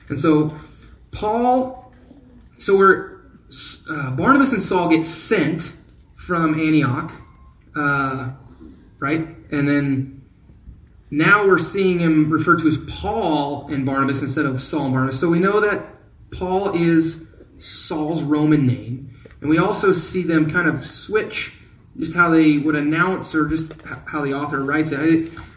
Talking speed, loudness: 145 wpm, -19 LUFS